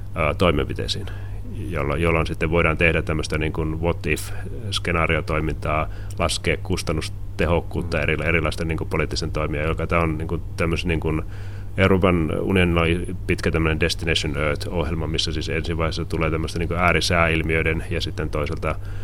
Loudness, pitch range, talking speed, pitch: -22 LUFS, 80-95 Hz, 135 wpm, 85 Hz